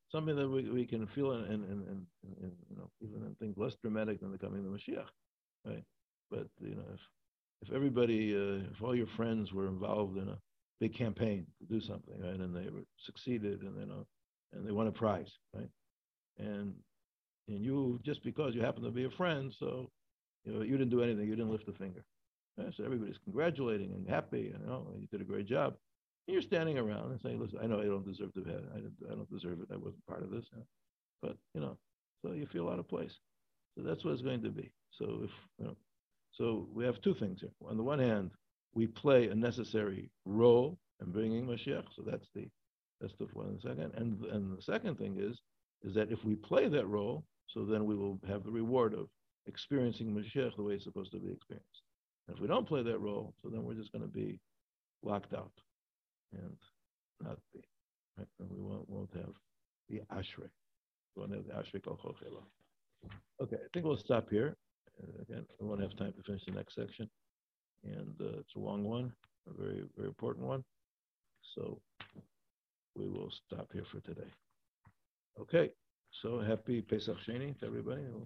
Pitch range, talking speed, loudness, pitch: 100-120 Hz, 205 wpm, -39 LUFS, 110 Hz